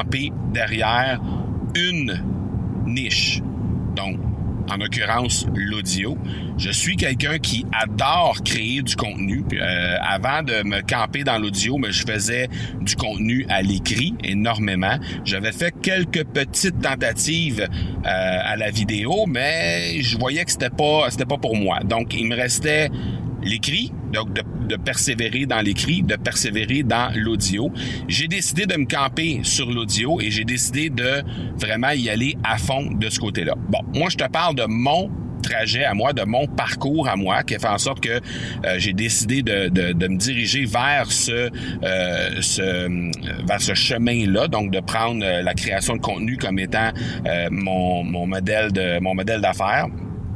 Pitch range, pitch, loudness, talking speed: 100-125 Hz, 115 Hz, -21 LUFS, 165 wpm